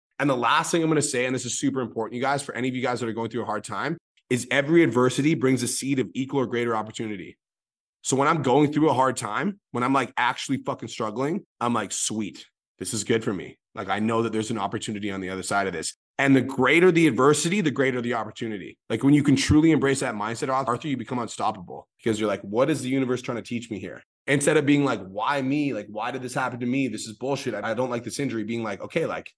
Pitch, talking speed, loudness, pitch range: 125 Hz, 270 wpm, -24 LUFS, 115-140 Hz